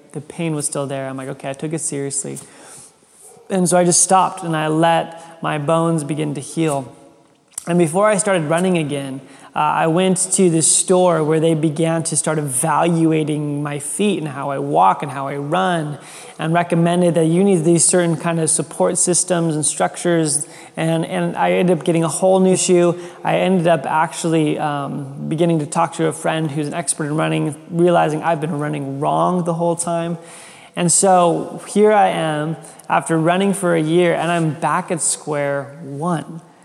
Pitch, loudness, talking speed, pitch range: 165 Hz, -17 LUFS, 190 wpm, 150-175 Hz